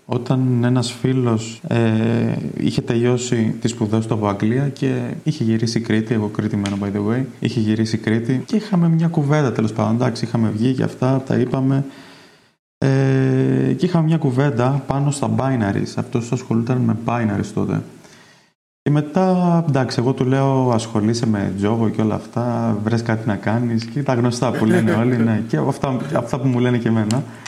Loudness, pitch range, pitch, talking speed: -19 LUFS, 110-135 Hz, 120 Hz, 175 wpm